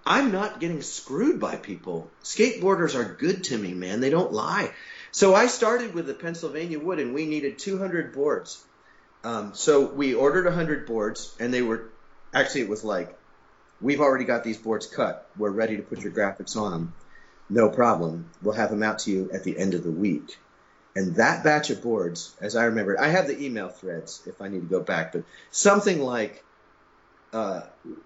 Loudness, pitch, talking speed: -25 LUFS, 125 Hz, 190 wpm